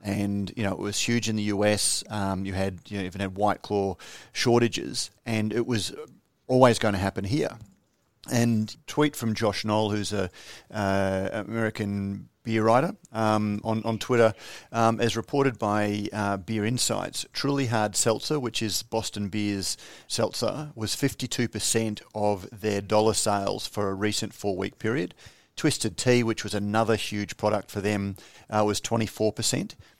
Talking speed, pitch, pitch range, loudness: 160 wpm, 105 Hz, 100-115 Hz, -27 LUFS